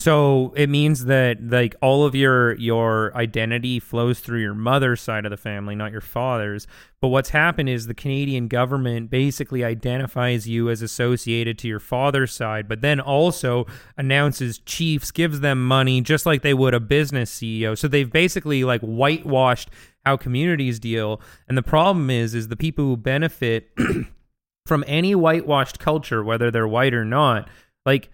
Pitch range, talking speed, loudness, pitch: 115-140 Hz, 170 wpm, -21 LUFS, 125 Hz